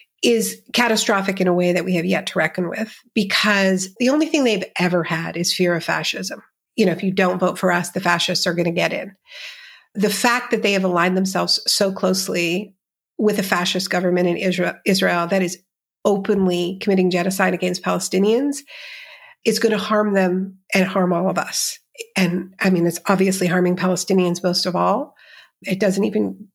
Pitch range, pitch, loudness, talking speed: 180-215 Hz, 190 Hz, -19 LUFS, 190 wpm